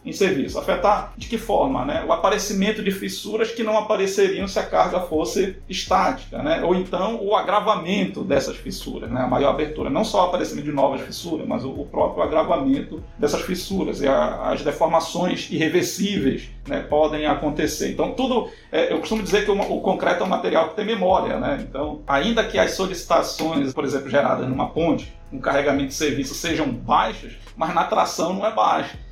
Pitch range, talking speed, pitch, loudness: 160-215 Hz, 180 wpm, 190 Hz, -22 LUFS